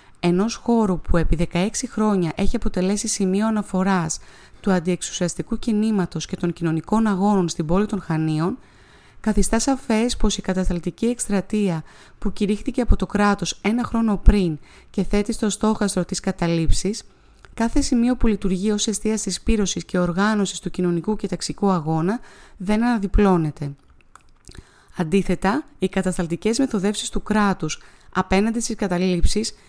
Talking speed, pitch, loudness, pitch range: 135 wpm, 200 Hz, -22 LUFS, 180-215 Hz